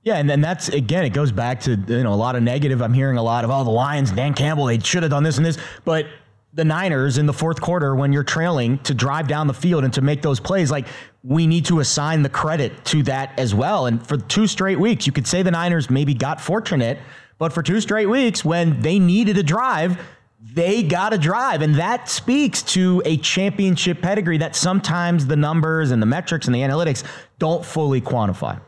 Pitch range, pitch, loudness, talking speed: 135-175 Hz, 150 Hz, -19 LUFS, 230 wpm